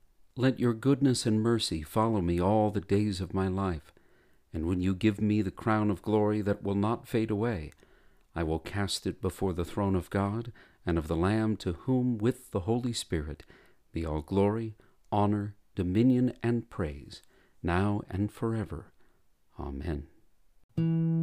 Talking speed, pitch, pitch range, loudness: 160 wpm, 100 Hz, 90-115 Hz, -30 LUFS